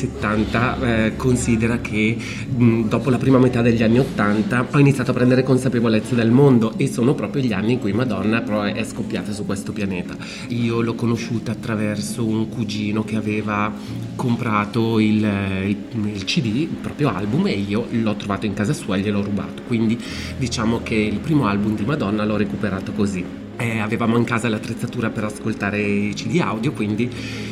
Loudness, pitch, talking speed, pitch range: -20 LUFS, 110 Hz, 175 wpm, 105-120 Hz